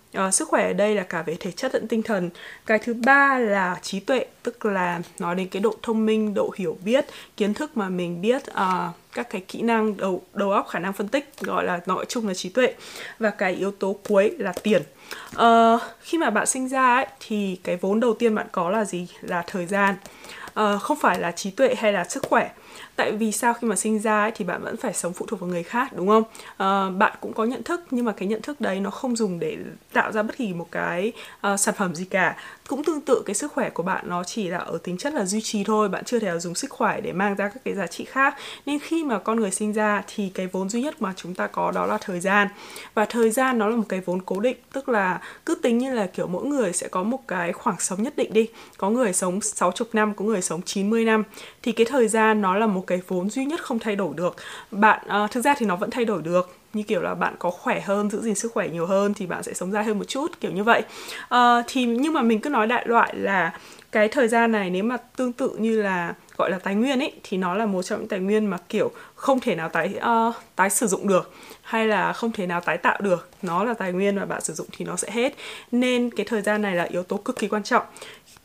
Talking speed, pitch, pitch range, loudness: 270 wpm, 215 Hz, 190-240 Hz, -24 LUFS